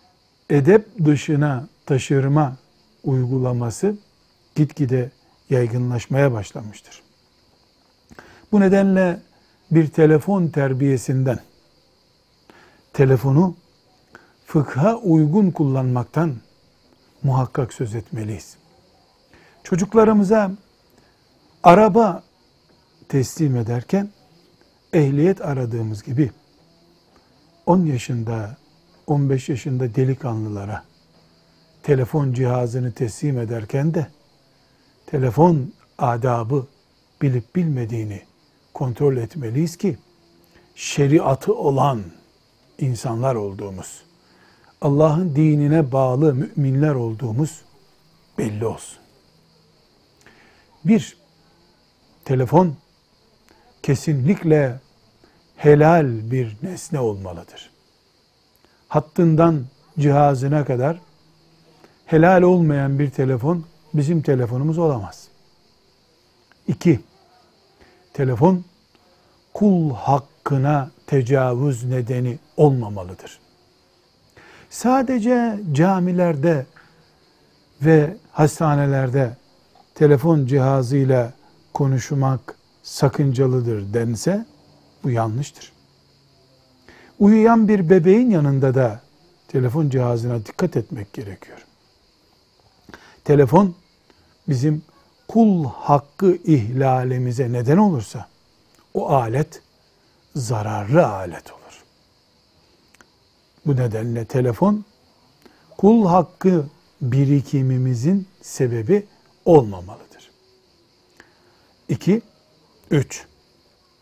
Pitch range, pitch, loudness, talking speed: 125-165 Hz, 140 Hz, -19 LUFS, 65 wpm